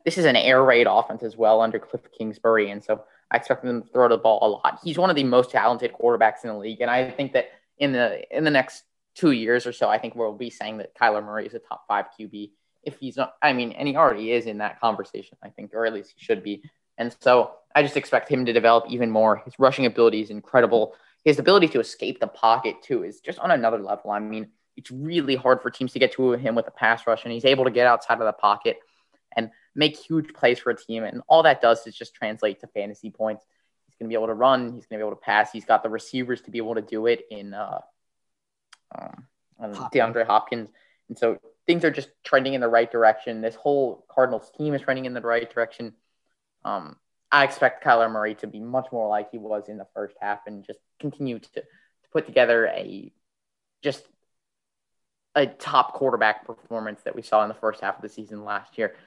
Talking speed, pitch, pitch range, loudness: 240 wpm, 115 Hz, 110-130 Hz, -23 LUFS